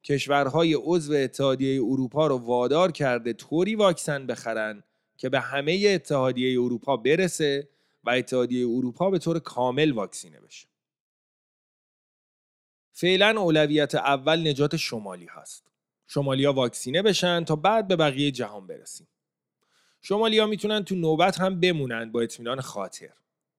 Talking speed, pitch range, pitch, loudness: 135 wpm, 125-175 Hz, 145 Hz, -24 LUFS